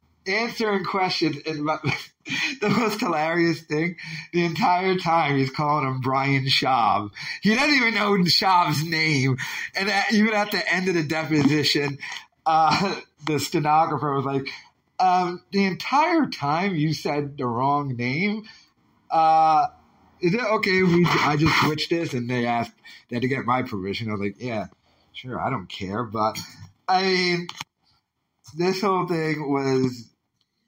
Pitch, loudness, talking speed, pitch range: 160 Hz, -22 LUFS, 155 wpm, 140-185 Hz